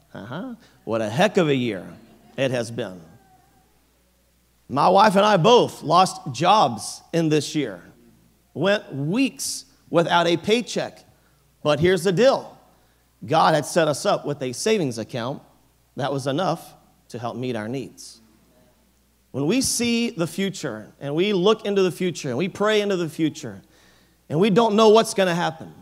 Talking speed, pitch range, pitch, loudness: 165 wpm, 125-195 Hz, 155 Hz, -21 LUFS